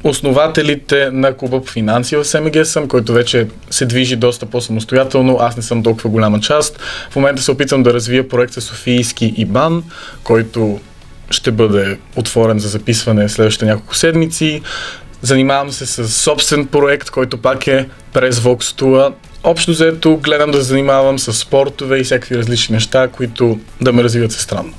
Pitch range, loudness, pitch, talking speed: 115-140 Hz, -13 LUFS, 130 Hz, 165 wpm